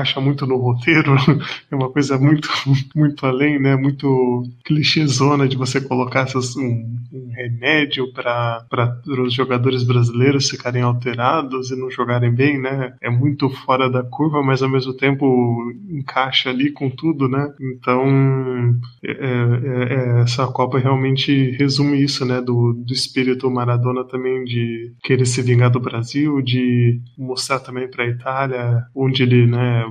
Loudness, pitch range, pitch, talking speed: -18 LUFS, 125-135 Hz, 130 Hz, 150 wpm